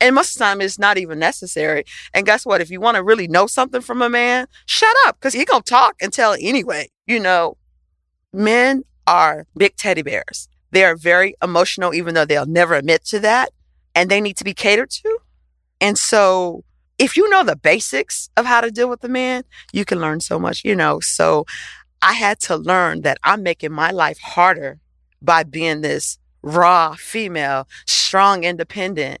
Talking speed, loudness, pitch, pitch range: 200 wpm, -16 LUFS, 190 Hz, 165-240 Hz